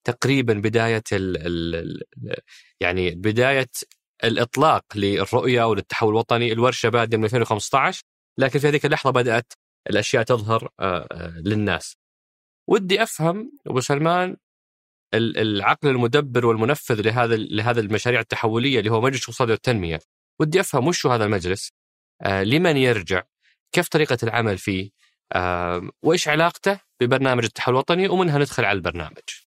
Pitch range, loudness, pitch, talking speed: 105-140 Hz, -21 LUFS, 120 Hz, 120 wpm